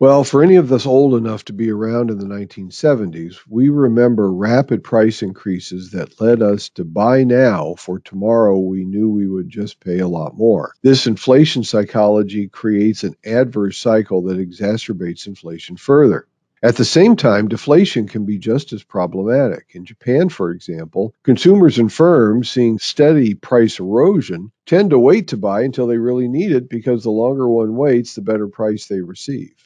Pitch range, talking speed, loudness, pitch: 100-125 Hz, 175 wpm, -15 LUFS, 110 Hz